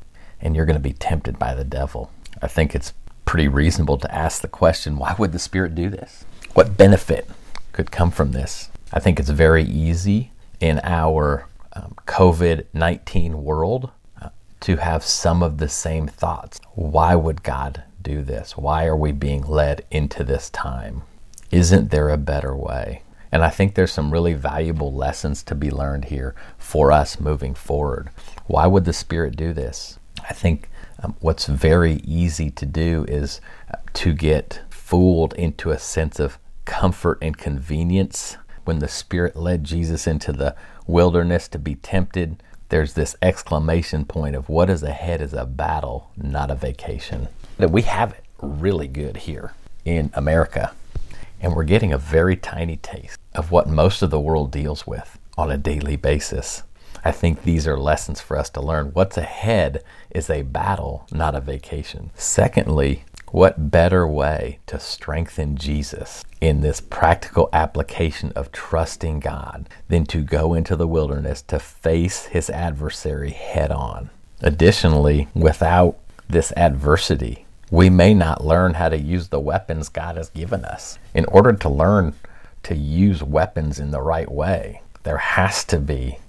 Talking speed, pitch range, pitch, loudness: 165 wpm, 75-85 Hz, 80 Hz, -20 LUFS